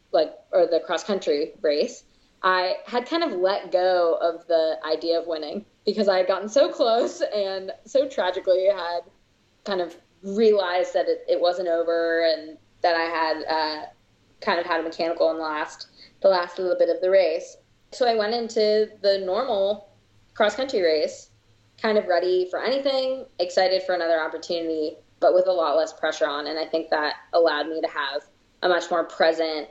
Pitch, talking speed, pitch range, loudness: 180 Hz, 185 wpm, 165-210 Hz, -23 LUFS